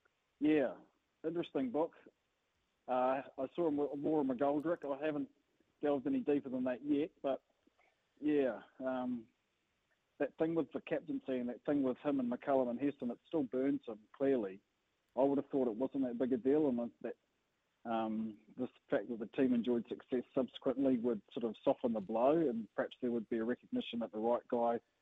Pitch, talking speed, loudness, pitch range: 130 Hz, 185 wpm, -37 LUFS, 120-145 Hz